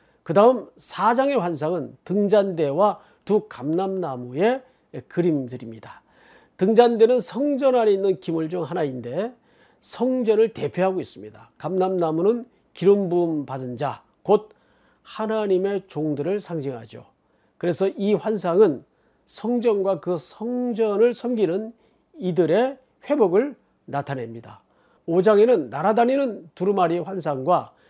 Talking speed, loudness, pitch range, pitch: 255 characters per minute, -22 LUFS, 160-225 Hz, 195 Hz